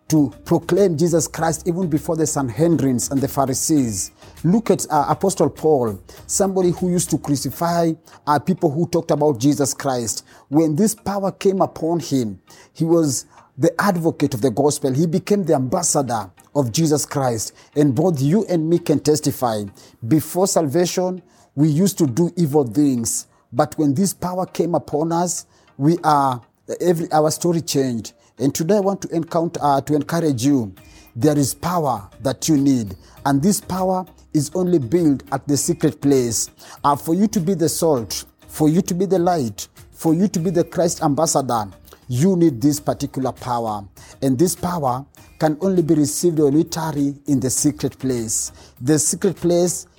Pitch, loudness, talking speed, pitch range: 155 Hz, -19 LUFS, 170 wpm, 135-170 Hz